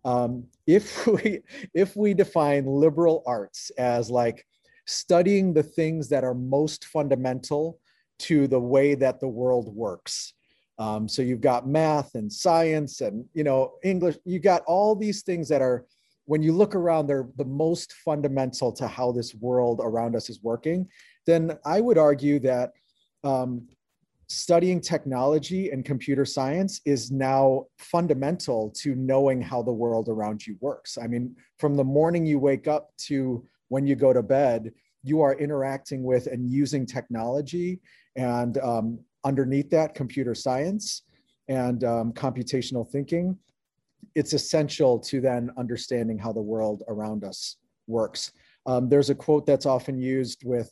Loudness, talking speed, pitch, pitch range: -25 LUFS, 155 wpm, 135 Hz, 125-155 Hz